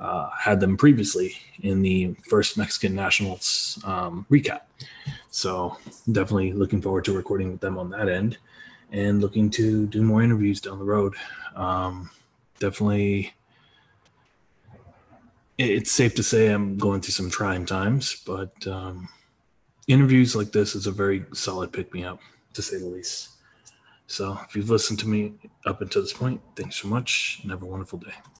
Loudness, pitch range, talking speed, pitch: -24 LUFS, 95-110 Hz, 165 wpm, 100 Hz